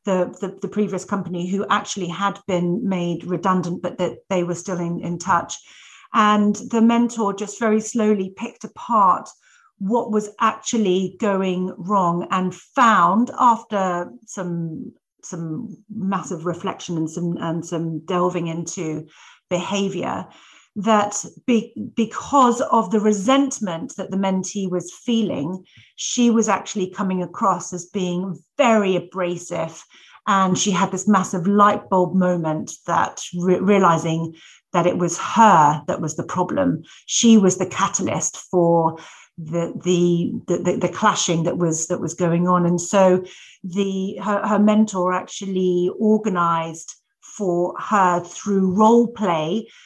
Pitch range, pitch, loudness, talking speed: 175-210 Hz, 190 Hz, -20 LUFS, 135 wpm